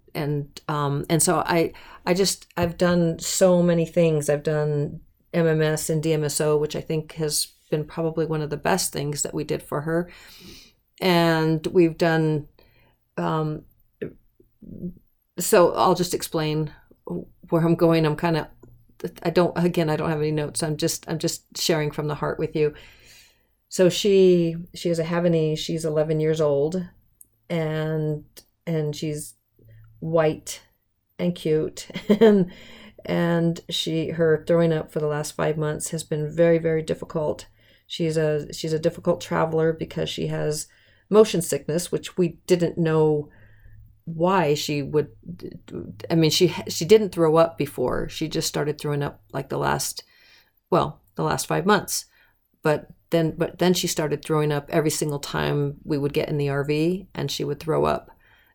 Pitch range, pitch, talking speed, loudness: 150-170 Hz, 160 Hz, 160 wpm, -23 LUFS